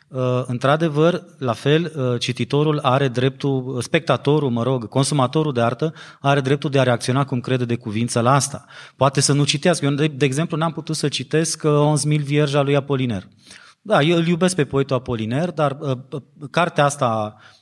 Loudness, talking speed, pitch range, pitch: -20 LUFS, 180 wpm, 125-155 Hz, 140 Hz